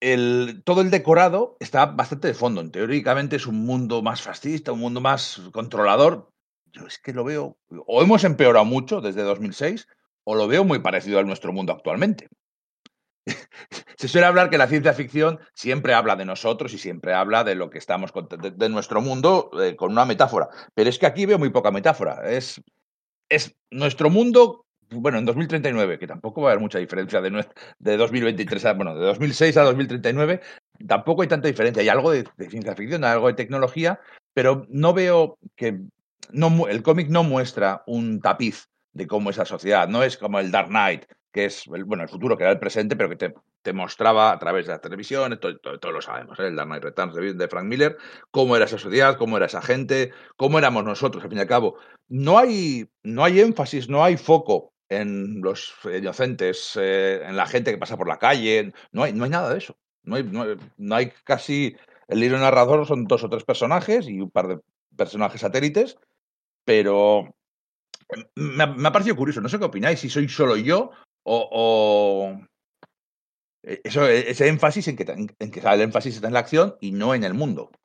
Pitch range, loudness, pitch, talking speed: 110-160 Hz, -21 LUFS, 130 Hz, 205 wpm